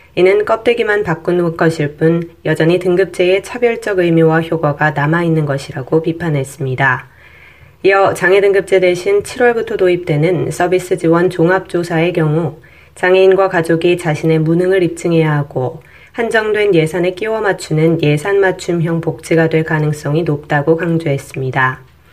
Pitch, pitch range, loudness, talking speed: 170 Hz, 160-185 Hz, -14 LUFS, 330 characters per minute